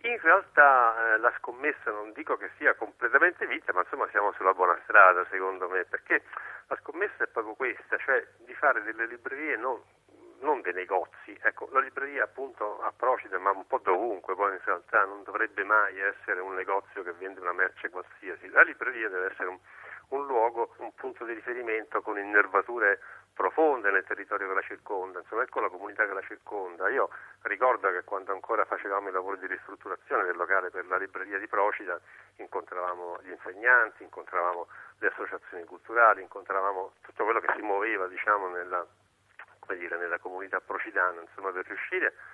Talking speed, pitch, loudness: 175 wpm, 115 Hz, -28 LUFS